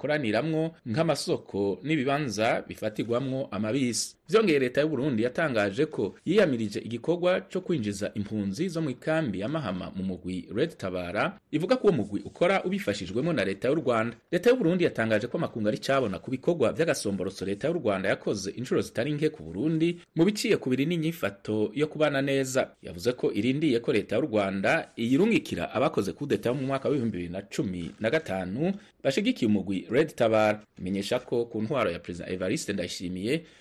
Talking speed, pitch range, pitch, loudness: 155 wpm, 100-160 Hz, 120 Hz, -28 LUFS